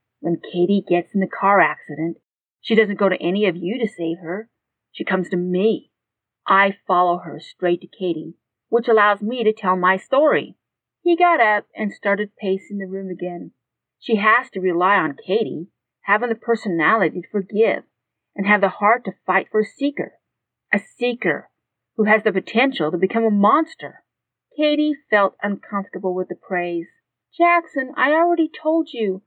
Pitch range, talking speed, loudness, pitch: 180-230 Hz, 170 wpm, -20 LUFS, 200 Hz